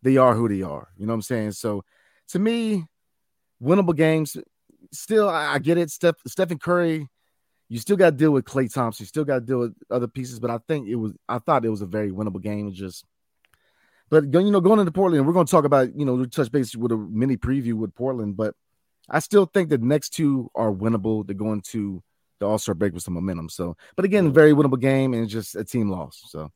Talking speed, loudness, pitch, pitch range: 235 wpm, -22 LUFS, 125 Hz, 105-155 Hz